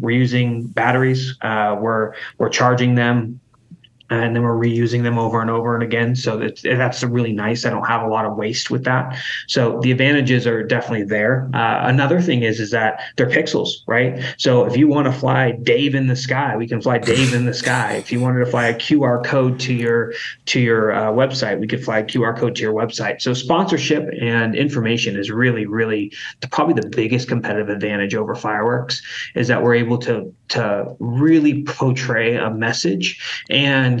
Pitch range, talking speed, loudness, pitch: 115-130 Hz, 200 wpm, -18 LUFS, 120 Hz